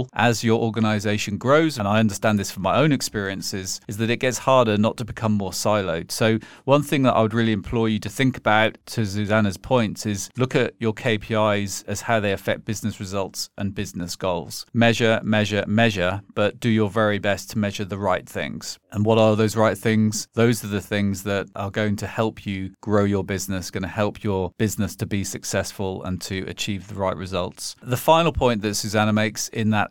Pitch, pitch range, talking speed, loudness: 105 Hz, 100-115 Hz, 210 wpm, -22 LUFS